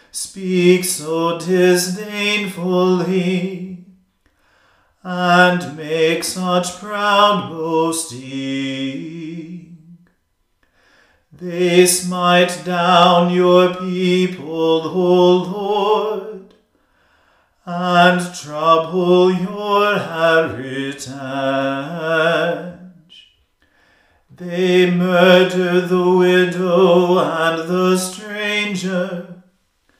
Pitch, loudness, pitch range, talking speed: 180 Hz, -16 LUFS, 165-185 Hz, 50 wpm